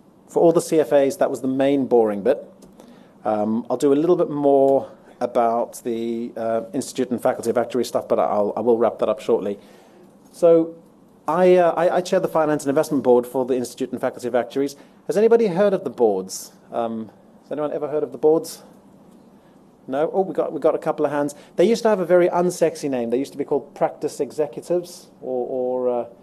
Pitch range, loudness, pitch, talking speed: 125-165 Hz, -21 LUFS, 140 Hz, 215 wpm